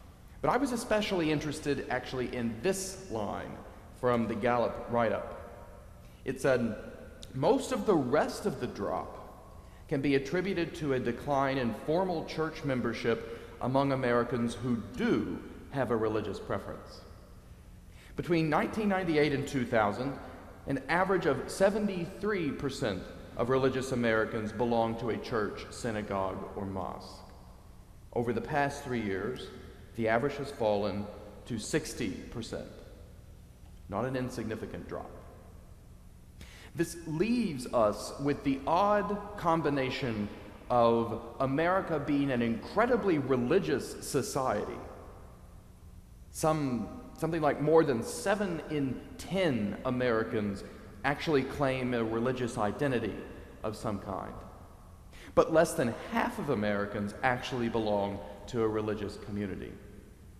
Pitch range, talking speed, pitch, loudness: 105-150 Hz, 115 wpm, 125 Hz, -32 LUFS